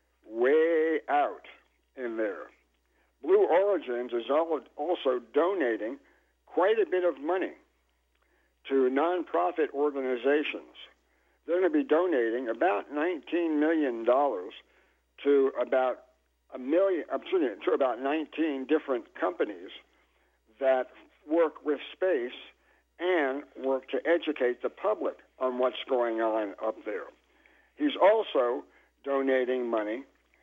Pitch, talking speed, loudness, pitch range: 145 Hz, 110 wpm, -29 LUFS, 130-180 Hz